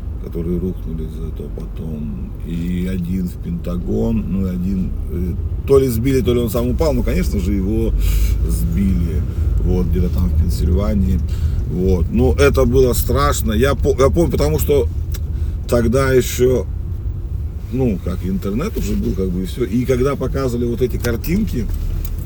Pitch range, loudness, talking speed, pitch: 85-110 Hz, -18 LUFS, 150 wpm, 90 Hz